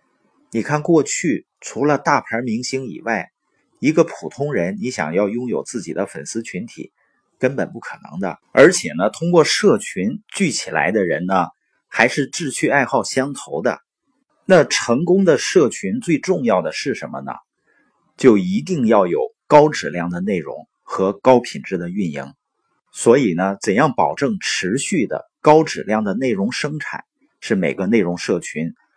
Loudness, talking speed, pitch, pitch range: -18 LUFS, 235 characters per minute, 140 Hz, 115-175 Hz